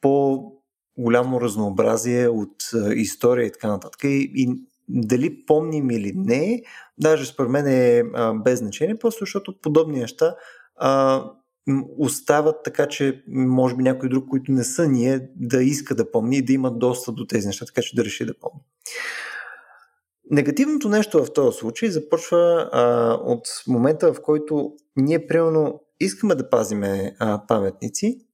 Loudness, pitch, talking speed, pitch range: -21 LUFS, 135 Hz, 150 wpm, 120-155 Hz